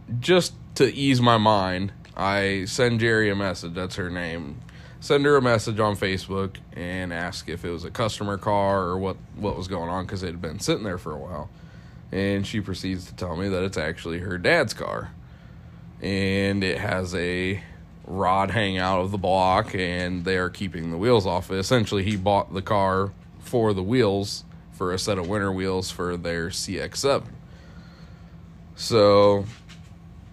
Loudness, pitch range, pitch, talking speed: -24 LUFS, 90-100 Hz, 95 Hz, 180 wpm